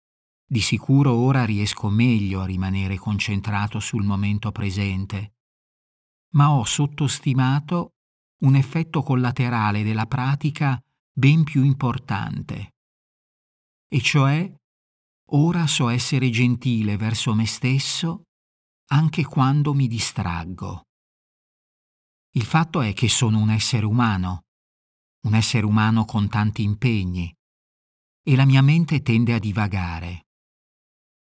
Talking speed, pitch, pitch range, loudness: 105 wpm, 115 Hz, 100-135 Hz, -21 LUFS